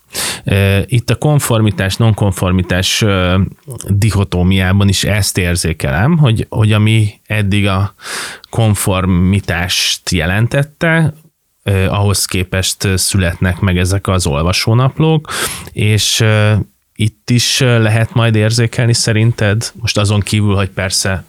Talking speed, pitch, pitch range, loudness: 95 wpm, 100 Hz, 95-115 Hz, -13 LUFS